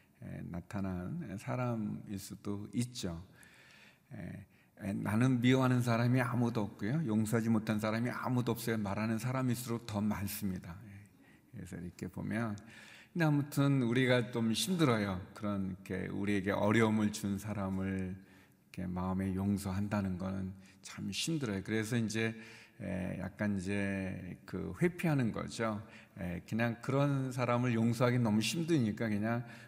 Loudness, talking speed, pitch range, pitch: -35 LUFS, 295 characters per minute, 100-120 Hz, 110 Hz